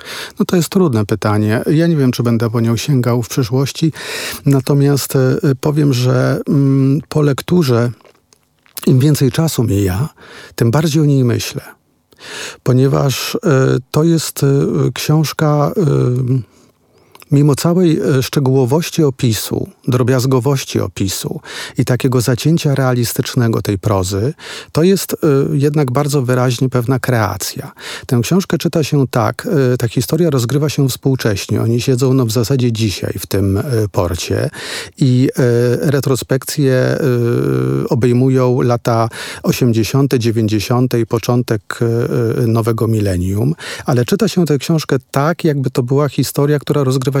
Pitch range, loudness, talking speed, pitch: 120-145 Hz, -15 LUFS, 130 wpm, 130 Hz